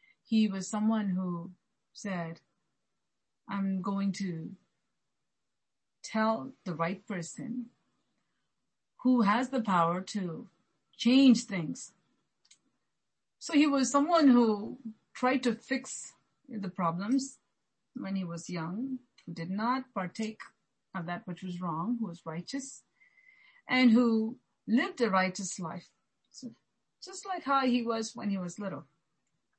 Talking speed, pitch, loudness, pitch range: 125 wpm, 220 Hz, -31 LUFS, 185-255 Hz